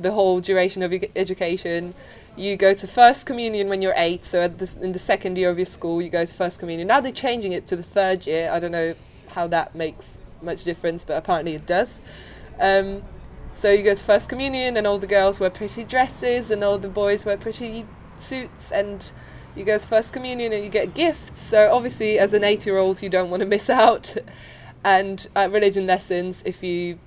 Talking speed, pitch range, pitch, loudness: 215 wpm, 180-210 Hz, 195 Hz, -21 LUFS